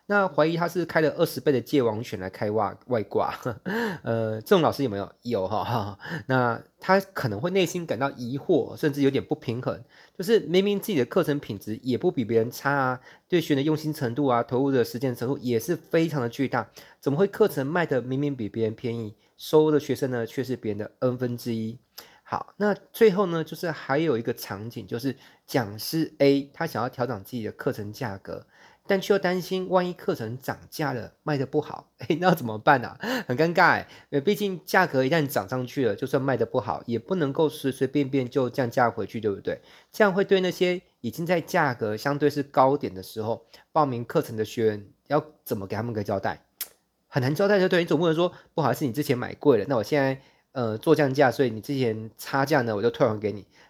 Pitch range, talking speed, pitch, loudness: 120-165 Hz, 320 characters per minute, 140 Hz, -26 LUFS